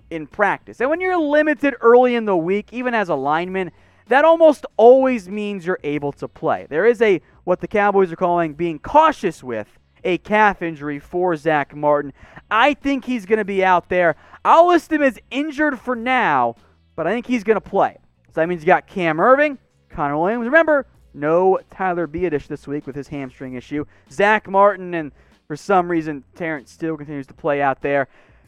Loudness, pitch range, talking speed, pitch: -18 LUFS, 150-240 Hz, 195 wpm, 180 Hz